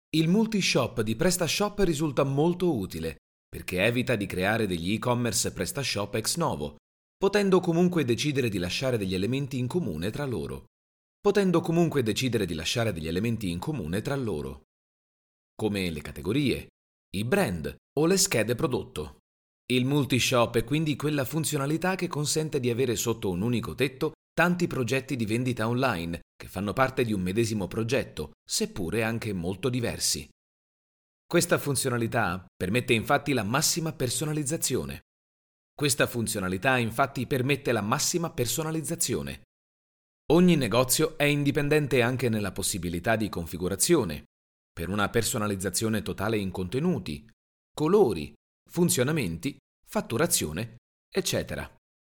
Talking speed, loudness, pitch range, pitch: 120 wpm, -27 LUFS, 95-150 Hz, 120 Hz